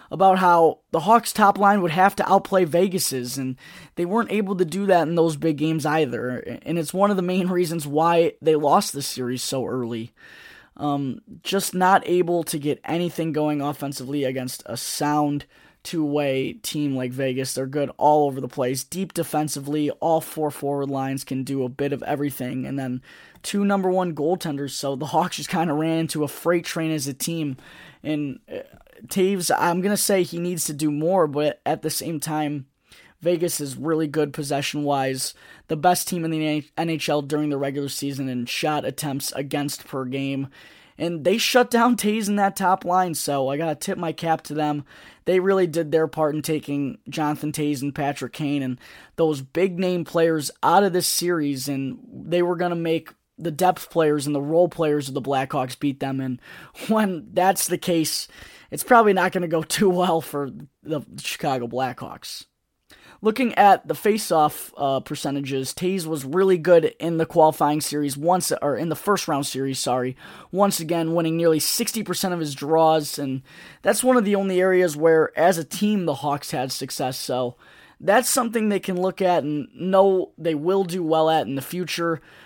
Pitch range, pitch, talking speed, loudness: 140-180 Hz, 160 Hz, 190 wpm, -22 LUFS